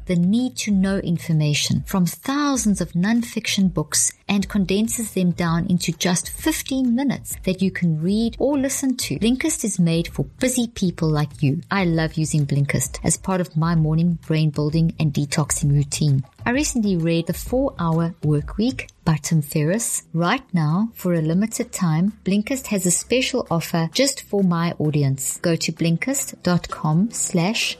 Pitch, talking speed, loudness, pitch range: 180 Hz, 165 wpm, -21 LUFS, 160-215 Hz